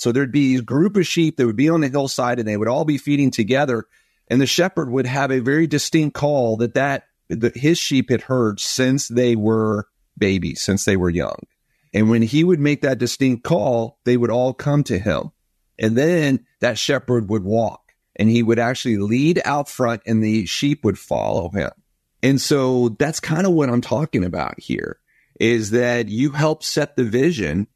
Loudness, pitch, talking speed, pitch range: -19 LUFS, 130 Hz, 205 wpm, 115-145 Hz